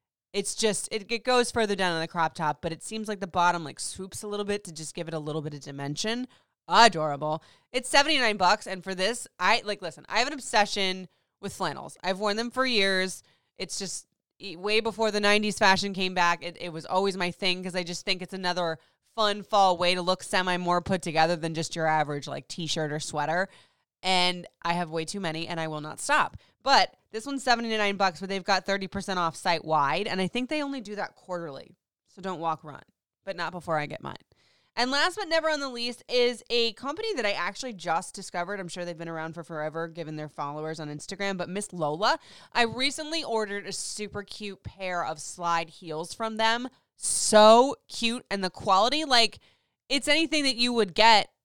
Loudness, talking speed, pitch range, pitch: -27 LUFS, 215 wpm, 170-220 Hz, 190 Hz